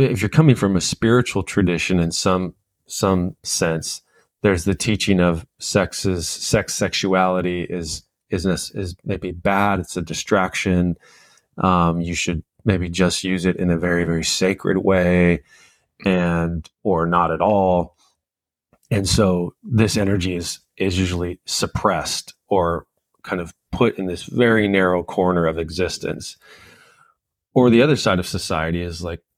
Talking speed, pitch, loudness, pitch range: 145 wpm, 90 Hz, -20 LUFS, 85-100 Hz